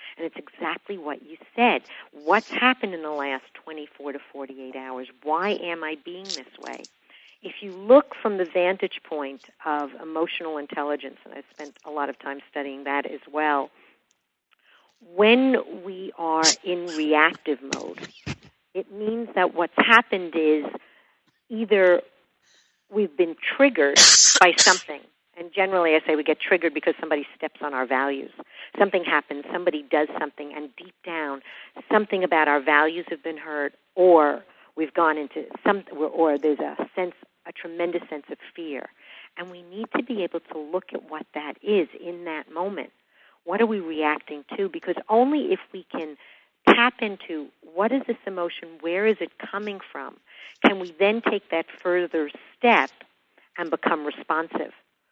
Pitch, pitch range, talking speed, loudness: 170 Hz, 150-195 Hz, 160 wpm, -22 LUFS